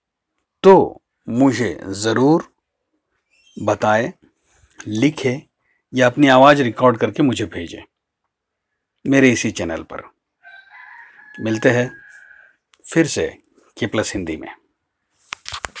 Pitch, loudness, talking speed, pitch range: 130 Hz, -17 LUFS, 90 wpm, 115-145 Hz